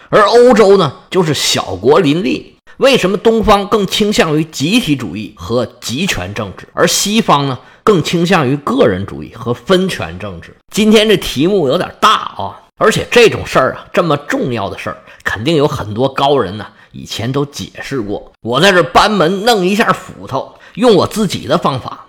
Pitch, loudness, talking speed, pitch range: 175 Hz, -12 LUFS, 270 characters per minute, 125-210 Hz